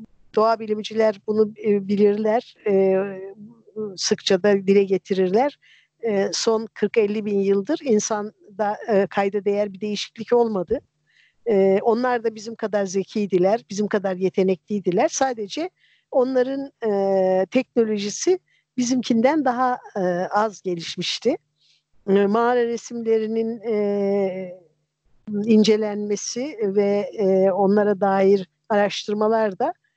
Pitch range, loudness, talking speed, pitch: 195-225 Hz, -21 LUFS, 80 wpm, 210 Hz